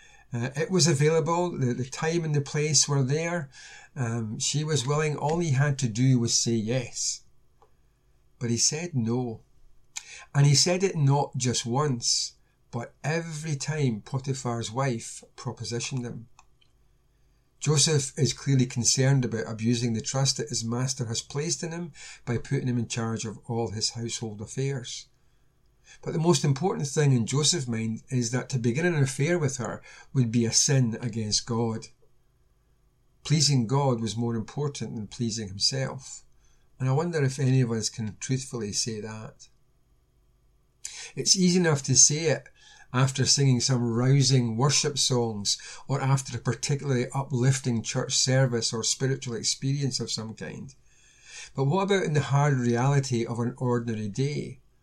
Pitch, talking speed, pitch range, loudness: 130 Hz, 160 wpm, 120-145 Hz, -26 LUFS